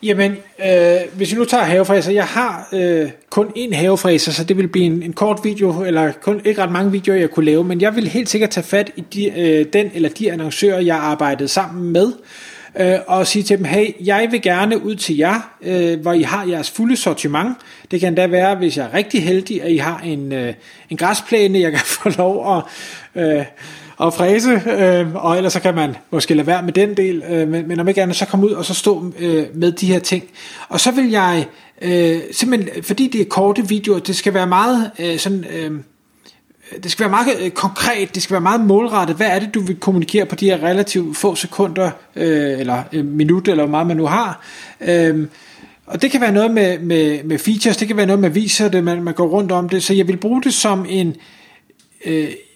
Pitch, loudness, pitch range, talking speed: 185 Hz, -16 LUFS, 170-205 Hz, 230 wpm